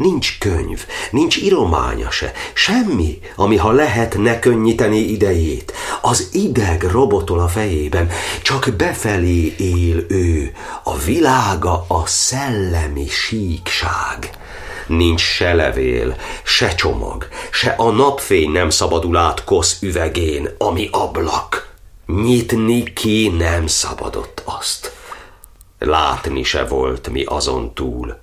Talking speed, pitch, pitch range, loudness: 110 wpm, 90 Hz, 85-110 Hz, -16 LUFS